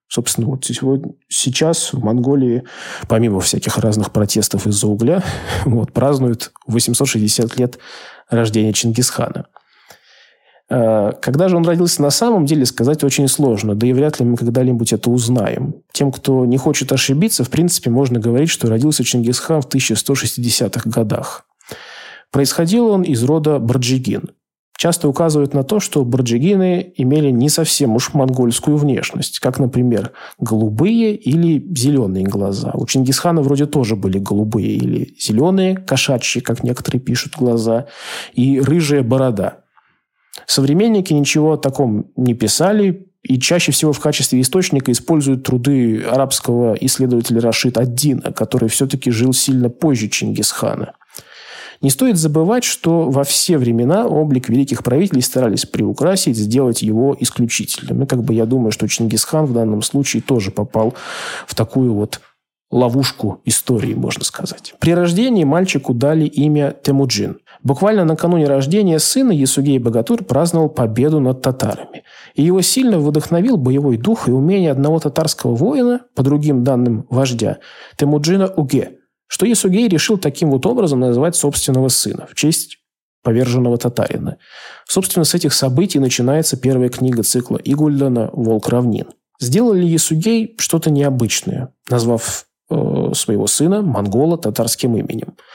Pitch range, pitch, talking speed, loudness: 120-155 Hz, 135 Hz, 135 wpm, -15 LUFS